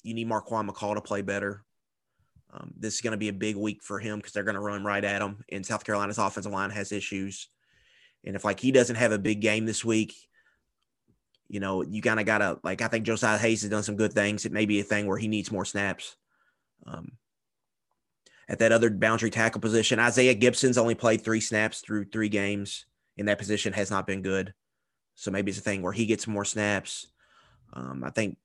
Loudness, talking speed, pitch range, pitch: -27 LUFS, 225 wpm, 100-110 Hz, 105 Hz